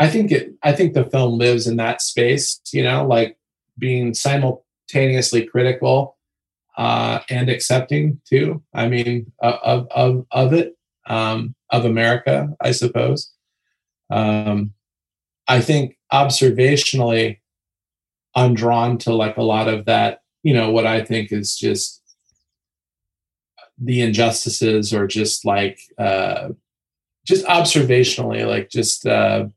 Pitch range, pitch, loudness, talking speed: 110-130 Hz, 120 Hz, -18 LUFS, 130 wpm